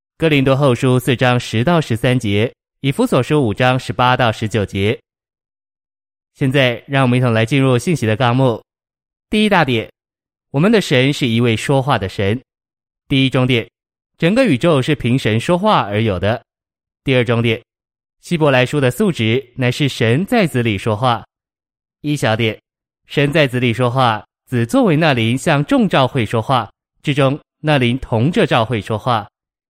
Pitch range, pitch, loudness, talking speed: 115-140 Hz, 125 Hz, -16 LUFS, 240 characters per minute